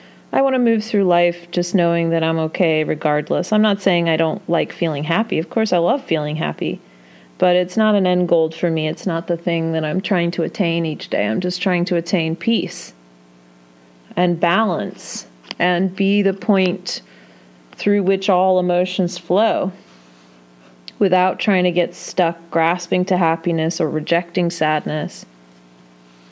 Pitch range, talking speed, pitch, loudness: 155-185 Hz, 165 wpm, 170 Hz, -18 LUFS